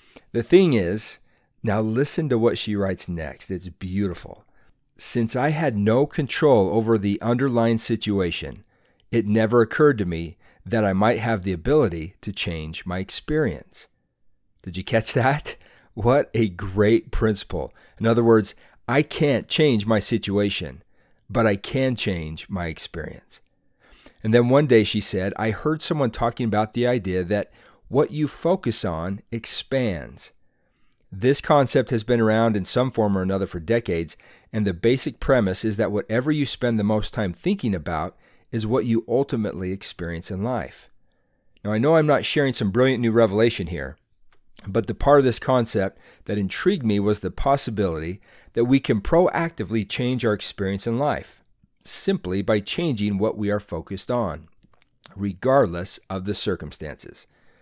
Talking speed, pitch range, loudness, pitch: 160 wpm, 95-125 Hz, -22 LUFS, 110 Hz